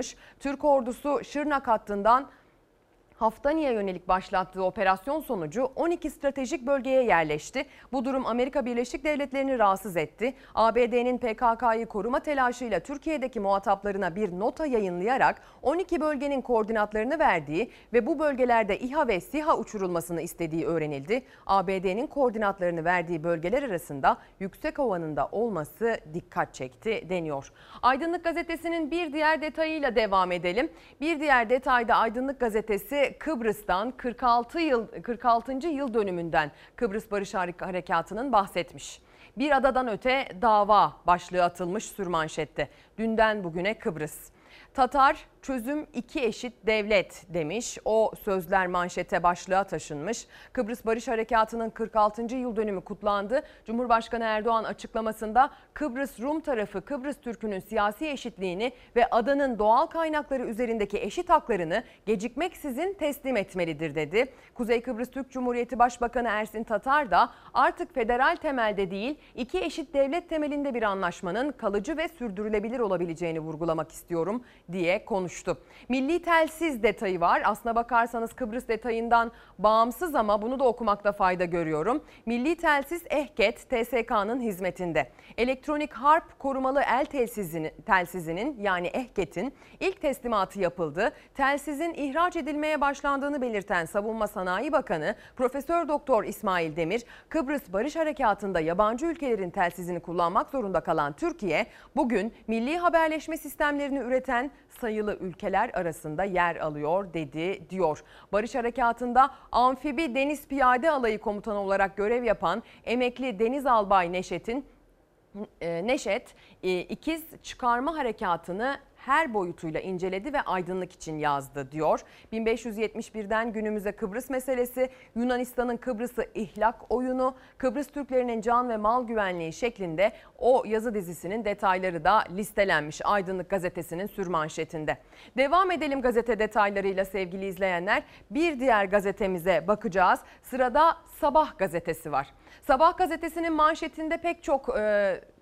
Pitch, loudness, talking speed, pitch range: 230 Hz, -28 LUFS, 120 wpm, 190-270 Hz